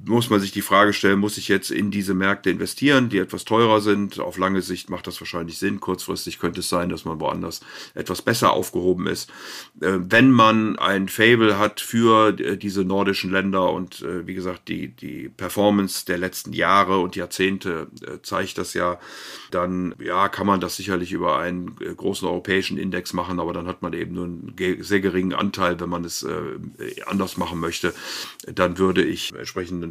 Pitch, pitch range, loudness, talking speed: 95 Hz, 90-100 Hz, -22 LUFS, 180 wpm